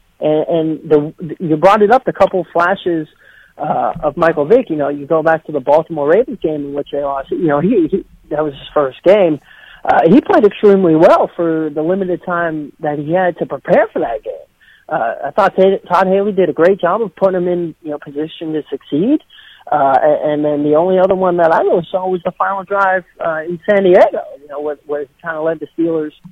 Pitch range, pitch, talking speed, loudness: 150-185 Hz, 165 Hz, 220 wpm, -14 LUFS